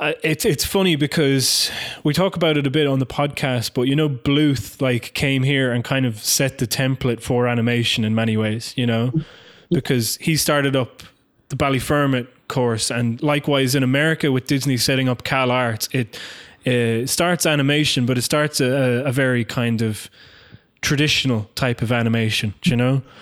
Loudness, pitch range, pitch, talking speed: -19 LUFS, 120-145 Hz, 130 Hz, 180 wpm